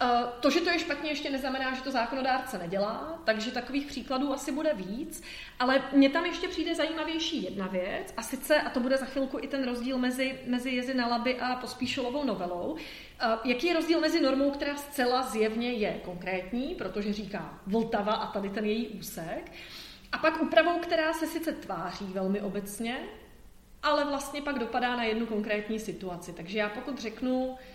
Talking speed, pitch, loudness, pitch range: 175 wpm, 255 Hz, -30 LUFS, 215-285 Hz